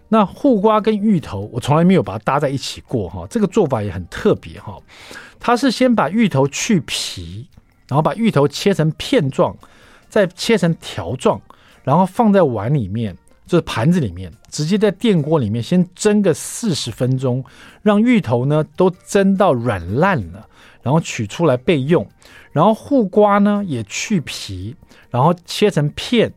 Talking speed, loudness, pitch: 245 characters per minute, -17 LUFS, 165 Hz